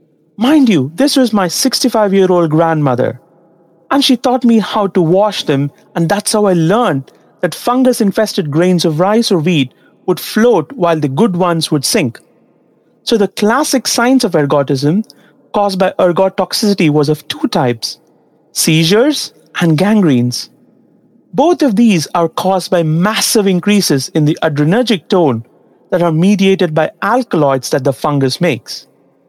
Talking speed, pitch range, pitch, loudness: 150 wpm, 160-215 Hz, 185 Hz, -12 LUFS